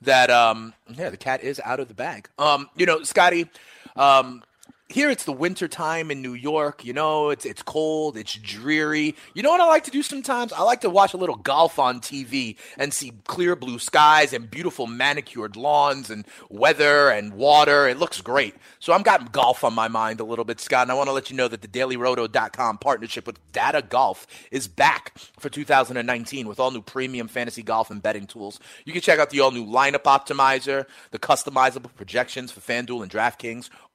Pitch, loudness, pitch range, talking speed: 135 Hz, -21 LUFS, 120-150 Hz, 205 wpm